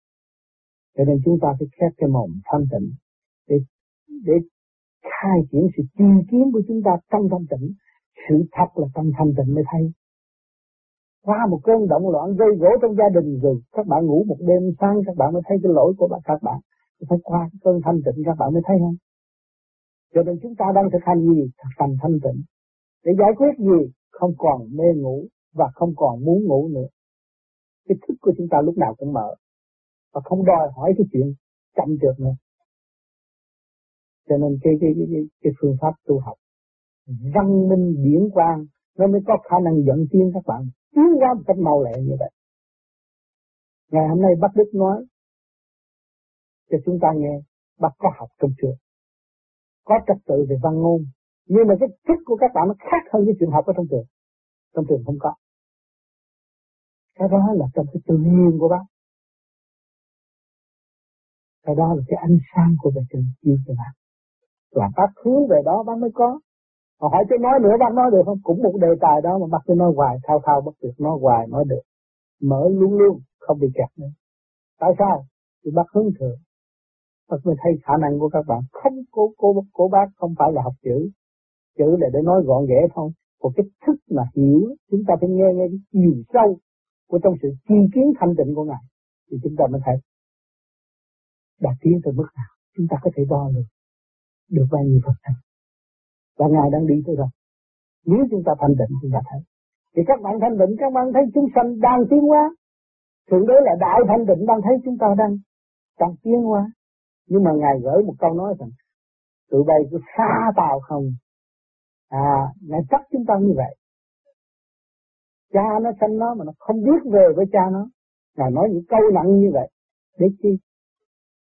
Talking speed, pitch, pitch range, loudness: 200 wpm, 170 Hz, 145-200 Hz, -19 LUFS